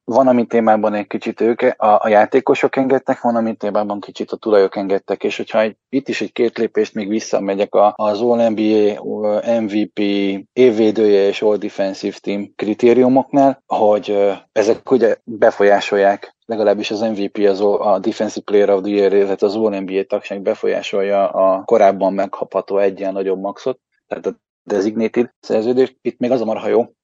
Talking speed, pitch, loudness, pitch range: 160 wpm, 105 Hz, -16 LUFS, 100-115 Hz